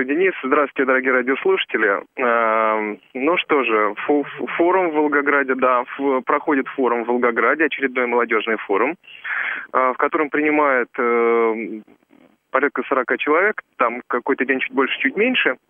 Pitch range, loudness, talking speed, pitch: 120-150 Hz, -19 LUFS, 120 wpm, 130 Hz